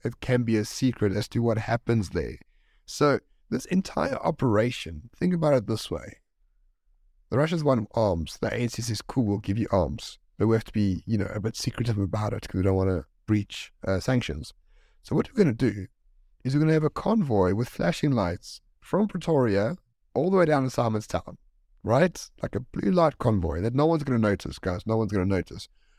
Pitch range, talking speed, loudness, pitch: 100-130 Hz, 215 wpm, -26 LUFS, 110 Hz